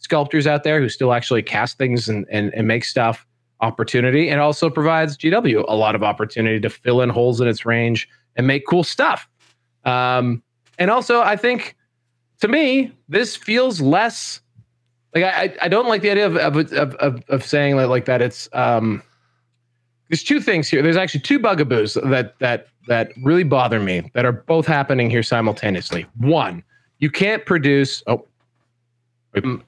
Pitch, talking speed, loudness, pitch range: 125 Hz, 175 wpm, -18 LUFS, 120-155 Hz